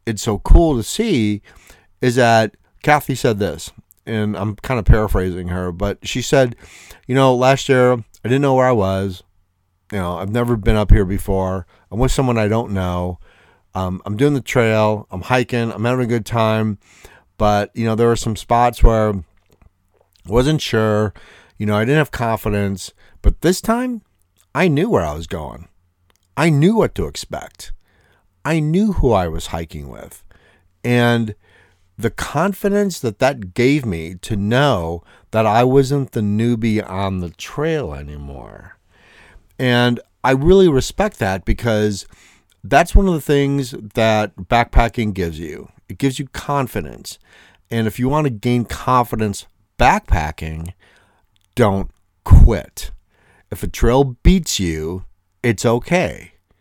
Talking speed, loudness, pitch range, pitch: 155 wpm, -18 LUFS, 90-125 Hz, 105 Hz